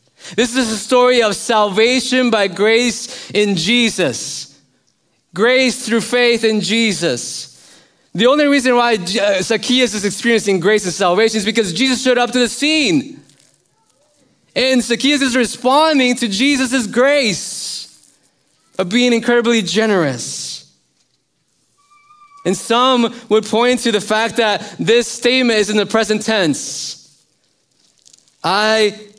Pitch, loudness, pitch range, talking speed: 225 Hz, -14 LUFS, 200-250 Hz, 125 wpm